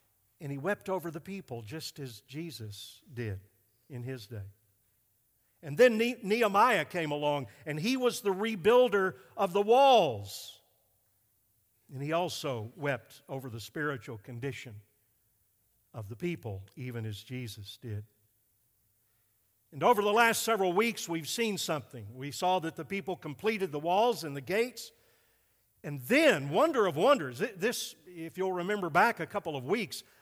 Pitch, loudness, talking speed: 140 Hz, -30 LUFS, 150 wpm